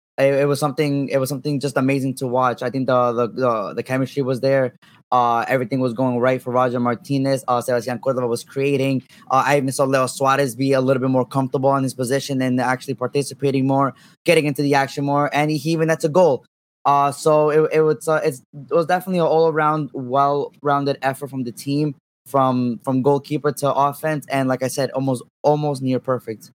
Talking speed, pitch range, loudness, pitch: 215 wpm, 130-145 Hz, -20 LUFS, 135 Hz